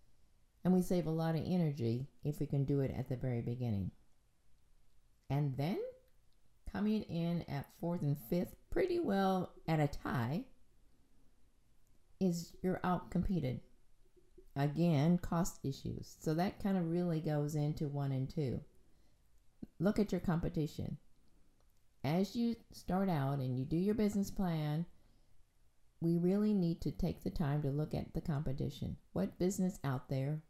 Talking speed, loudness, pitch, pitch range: 150 wpm, -37 LUFS, 165 Hz, 140-185 Hz